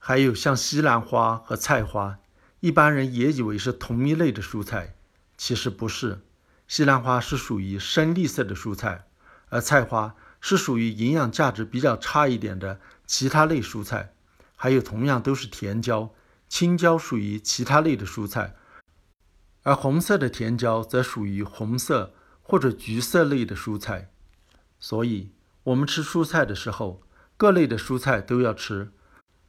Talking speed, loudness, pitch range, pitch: 230 characters per minute, -24 LUFS, 100-135 Hz, 115 Hz